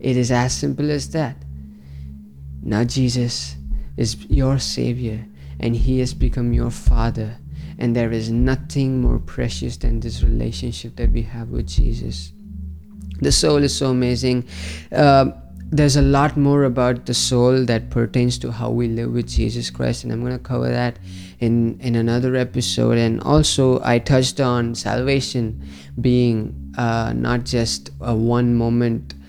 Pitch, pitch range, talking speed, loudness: 120 Hz, 85-125 Hz, 155 wpm, -20 LUFS